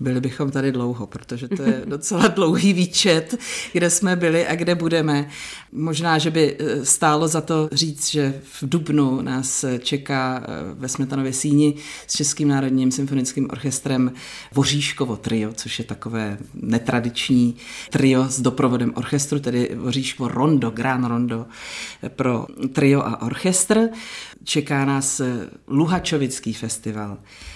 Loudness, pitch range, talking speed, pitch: -21 LUFS, 125-155 Hz, 130 wpm, 135 Hz